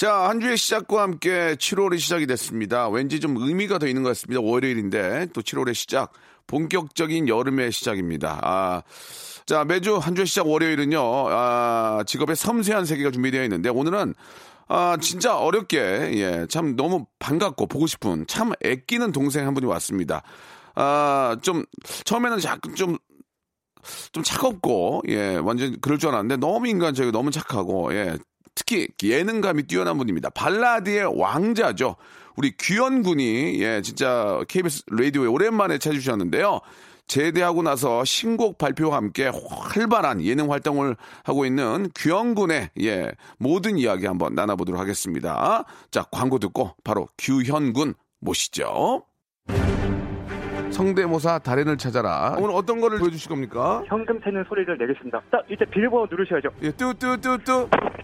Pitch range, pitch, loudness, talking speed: 125-195 Hz, 150 Hz, -23 LUFS, 320 characters per minute